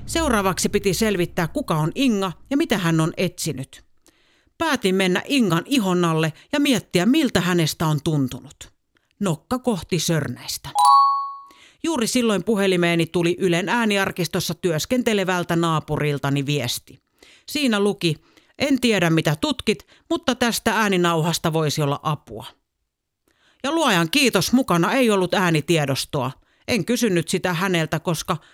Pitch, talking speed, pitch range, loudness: 180 Hz, 120 wpm, 160-235 Hz, -21 LUFS